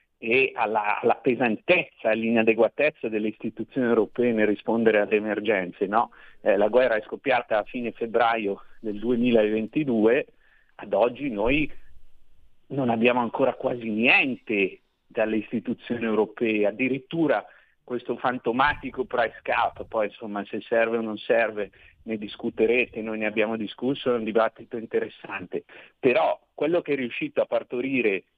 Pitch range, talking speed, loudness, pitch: 110-125 Hz, 135 wpm, -25 LUFS, 115 Hz